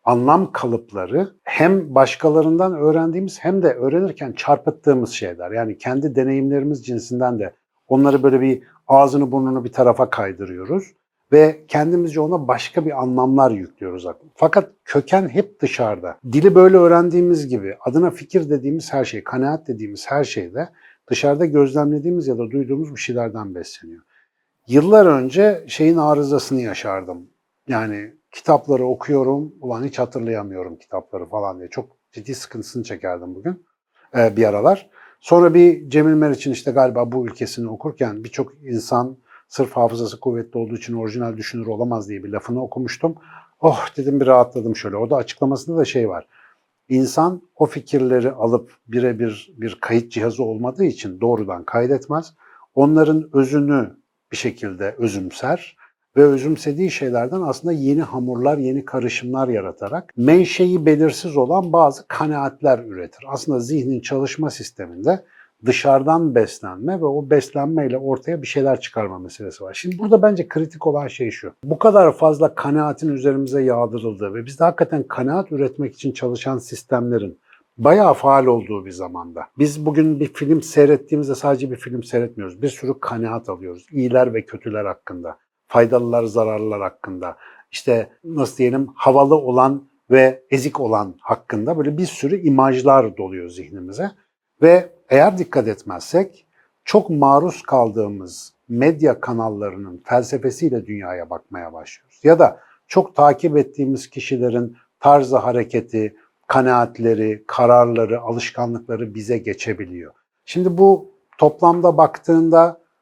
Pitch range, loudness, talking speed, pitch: 120-155 Hz, -17 LUFS, 130 wpm, 135 Hz